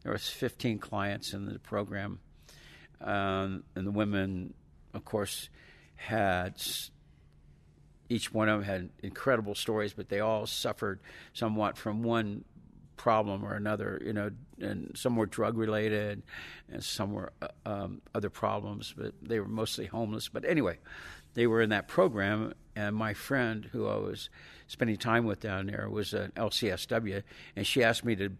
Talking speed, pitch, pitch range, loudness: 160 wpm, 105 Hz, 100-110 Hz, -33 LUFS